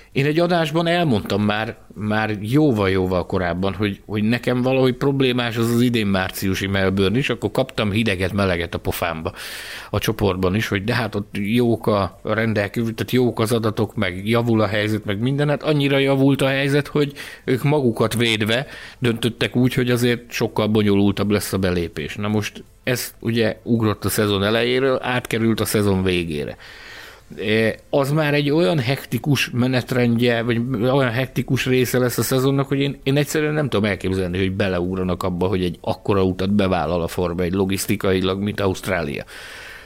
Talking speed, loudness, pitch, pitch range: 165 wpm, -20 LUFS, 110 Hz, 100-130 Hz